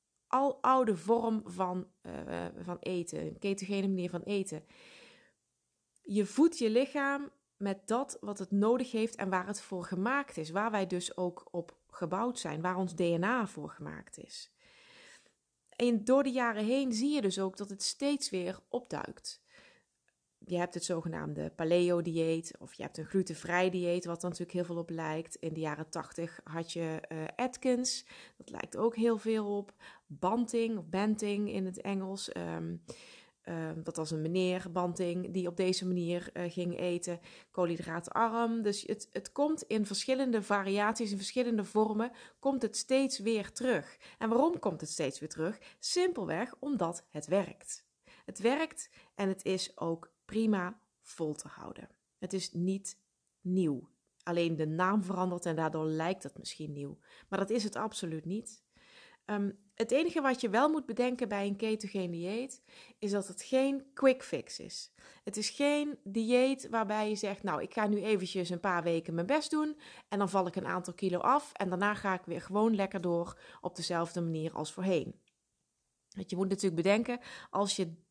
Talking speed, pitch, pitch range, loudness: 175 wpm, 195 Hz, 175-230 Hz, -34 LUFS